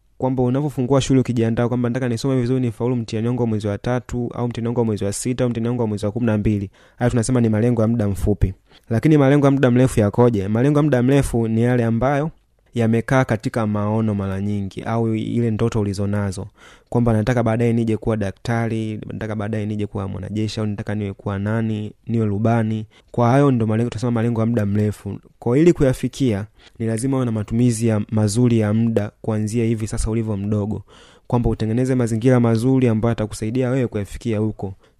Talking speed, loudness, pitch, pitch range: 165 wpm, -20 LUFS, 115 Hz, 105-125 Hz